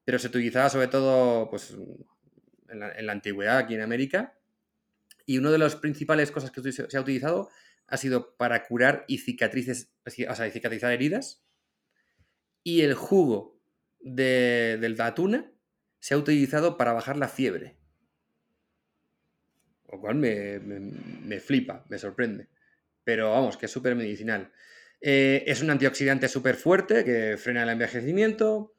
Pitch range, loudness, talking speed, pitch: 115-150 Hz, -26 LUFS, 150 wpm, 130 Hz